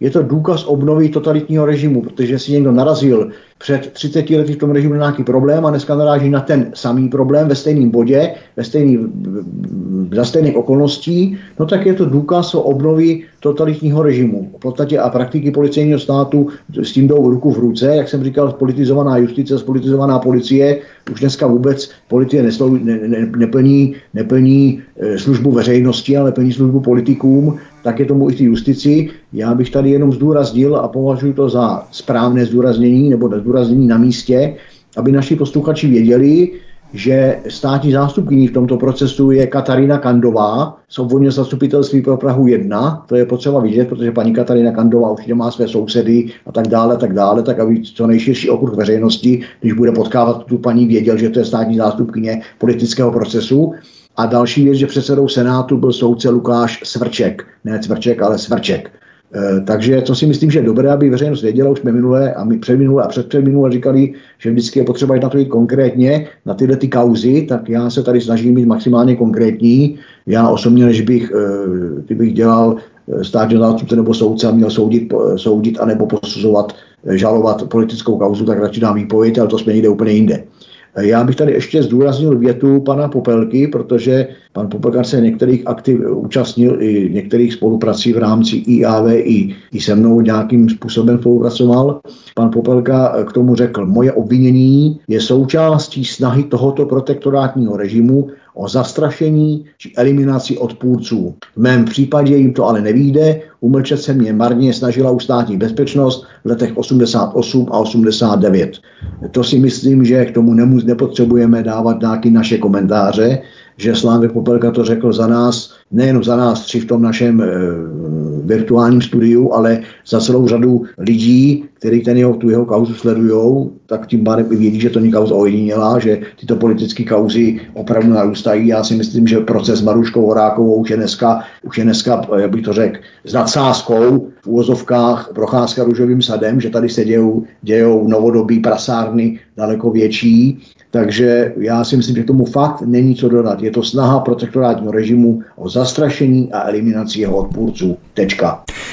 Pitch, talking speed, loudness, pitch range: 120 Hz, 165 wpm, -13 LUFS, 115-135 Hz